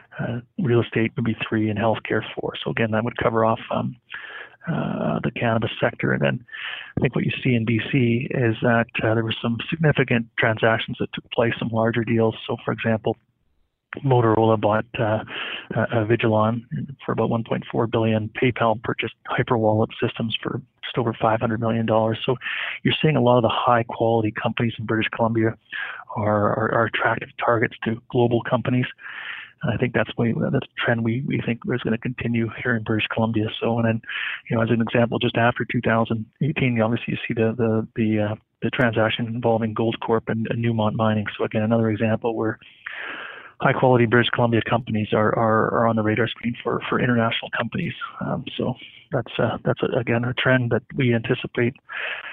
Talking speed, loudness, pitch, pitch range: 185 wpm, -22 LUFS, 115 Hz, 110-120 Hz